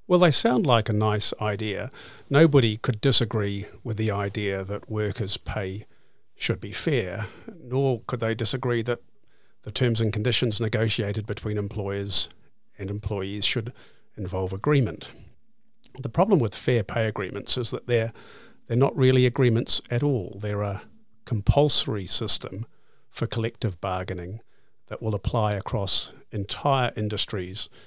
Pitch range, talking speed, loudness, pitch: 105-125 Hz, 140 wpm, -25 LUFS, 110 Hz